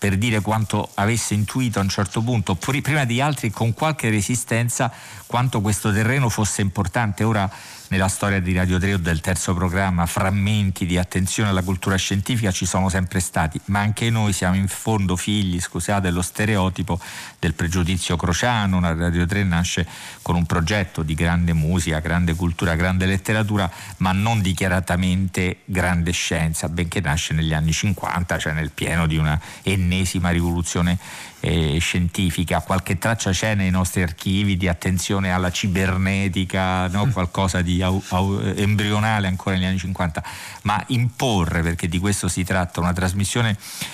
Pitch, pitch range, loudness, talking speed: 95 Hz, 90-105 Hz, -21 LUFS, 155 wpm